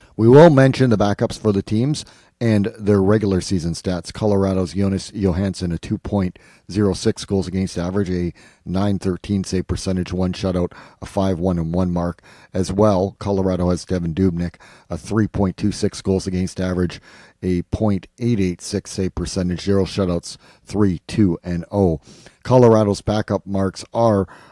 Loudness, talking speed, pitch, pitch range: -19 LUFS, 170 wpm, 95 Hz, 90-105 Hz